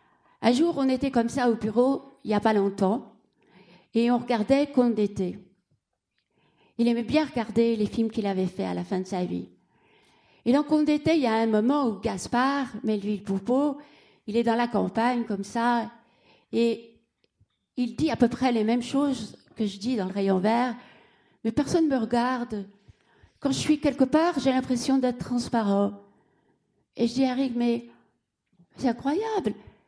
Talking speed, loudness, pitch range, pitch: 180 wpm, -26 LUFS, 210-265 Hz, 235 Hz